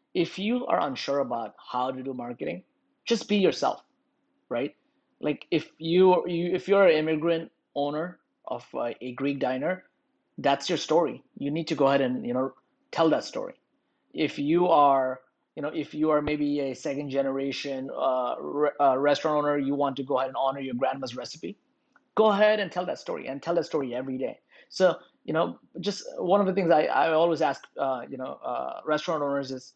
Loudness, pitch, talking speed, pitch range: -27 LUFS, 150 Hz, 195 wpm, 135-175 Hz